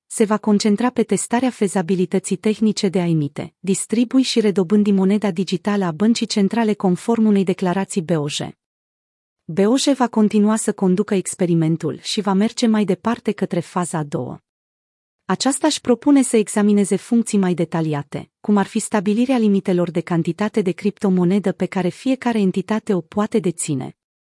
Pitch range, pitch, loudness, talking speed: 180-220 Hz, 200 Hz, -19 LUFS, 150 wpm